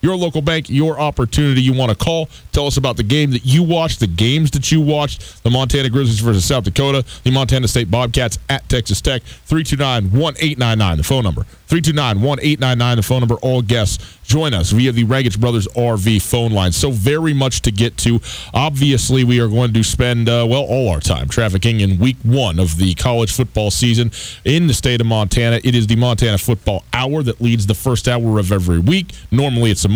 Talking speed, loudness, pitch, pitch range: 205 wpm, -15 LUFS, 120 Hz, 110-135 Hz